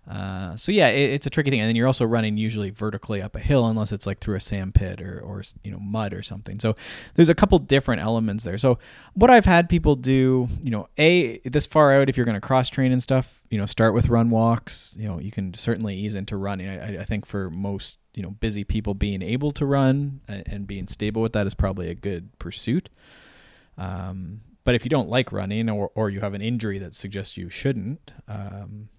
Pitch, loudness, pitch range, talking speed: 110 Hz, -23 LUFS, 100-130 Hz, 235 wpm